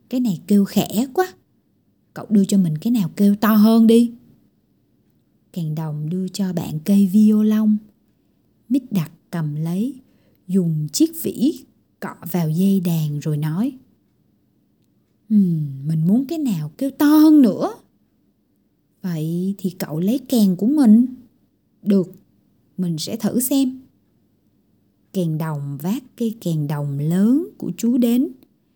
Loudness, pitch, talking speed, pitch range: -19 LUFS, 200 Hz, 135 wpm, 165-240 Hz